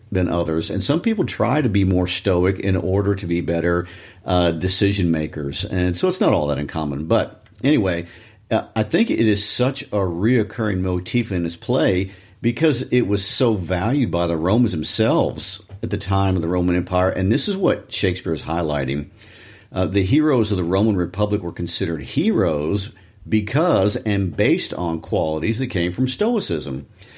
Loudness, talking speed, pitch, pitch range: -20 LUFS, 175 wpm, 95 Hz, 90-110 Hz